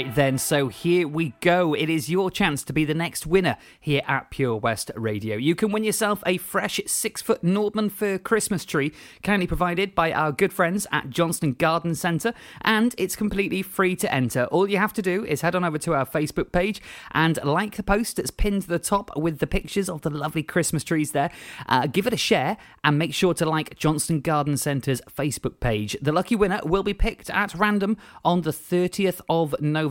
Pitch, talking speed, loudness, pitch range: 170 Hz, 215 wpm, -24 LUFS, 150-195 Hz